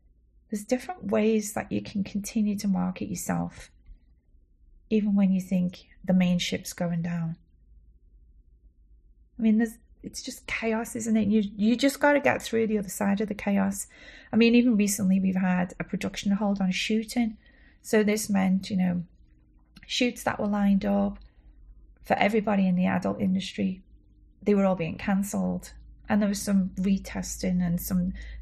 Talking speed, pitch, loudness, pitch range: 165 wpm, 195 Hz, -27 LUFS, 170-215 Hz